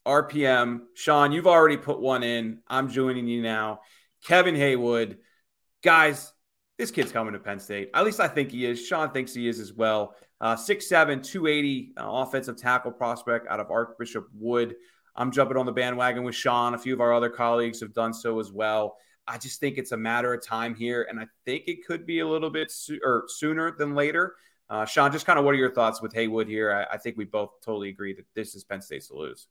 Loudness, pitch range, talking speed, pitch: -25 LUFS, 115-140 Hz, 225 wpm, 120 Hz